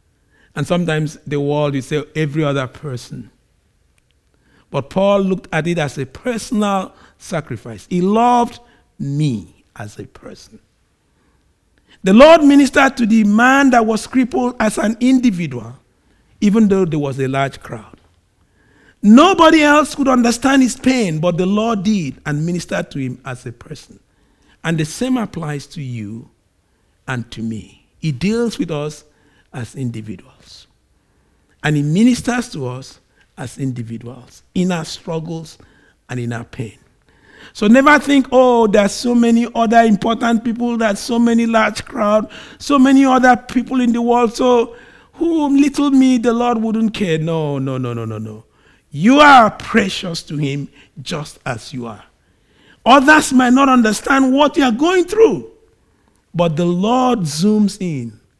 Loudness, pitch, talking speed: -15 LUFS, 180 Hz, 150 wpm